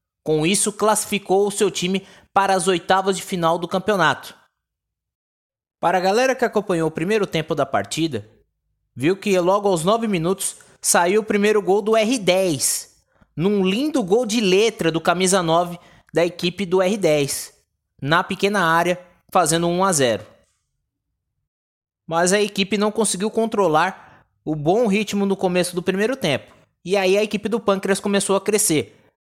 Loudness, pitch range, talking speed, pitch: -20 LUFS, 170-205 Hz, 155 wpm, 190 Hz